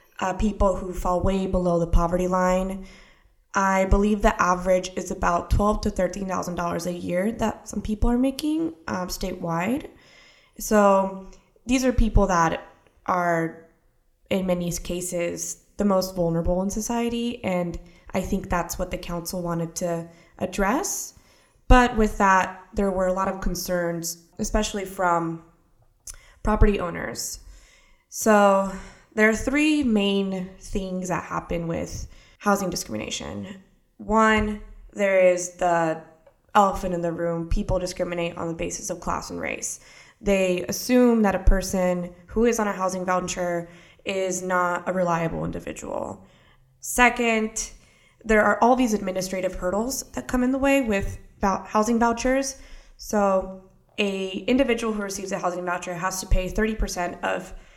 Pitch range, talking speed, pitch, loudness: 175-215 Hz, 140 wpm, 190 Hz, -24 LUFS